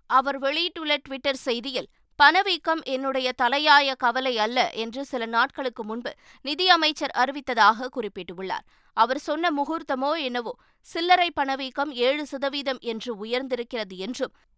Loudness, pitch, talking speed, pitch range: -24 LUFS, 270 Hz, 110 wpm, 245-285 Hz